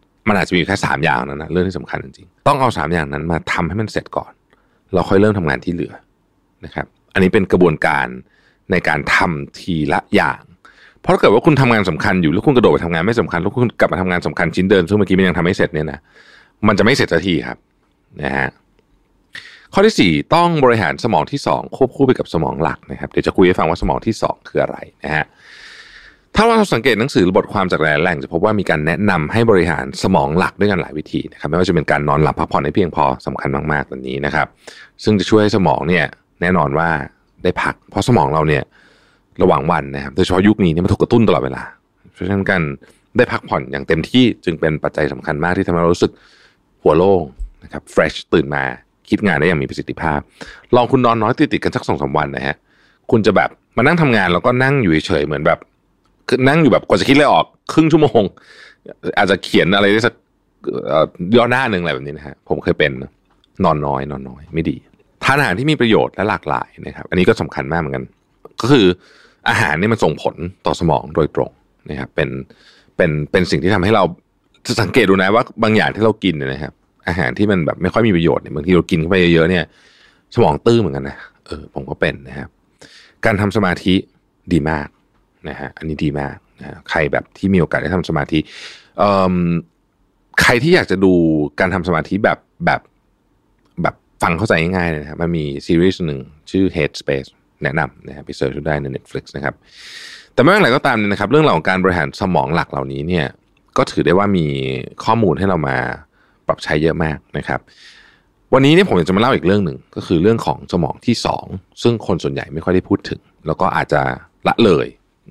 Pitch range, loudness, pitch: 75-100 Hz, -16 LUFS, 85 Hz